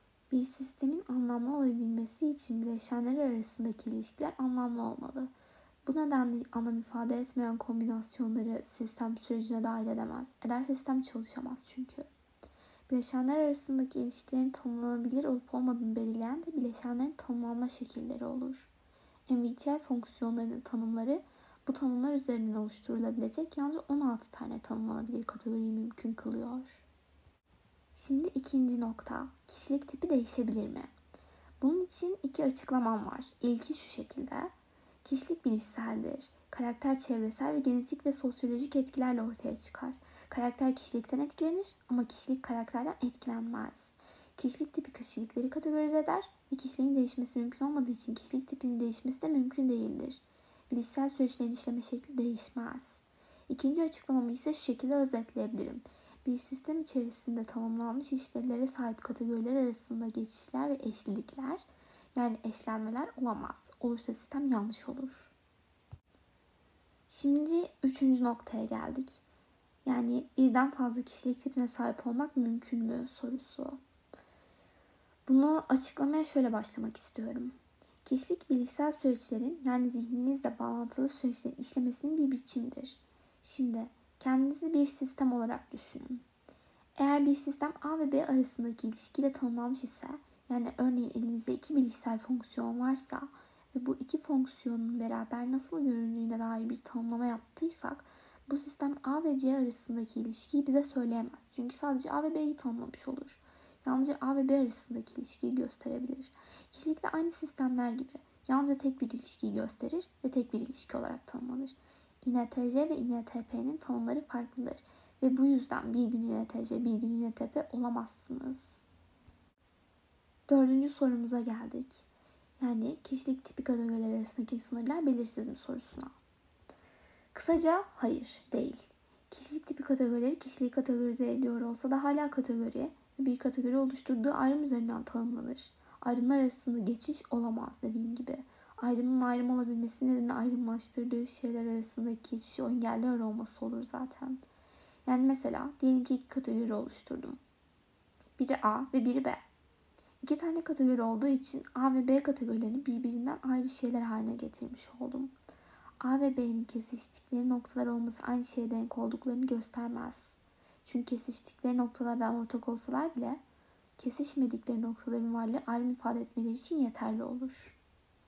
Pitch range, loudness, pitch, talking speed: 235-275 Hz, -35 LUFS, 255 Hz, 125 wpm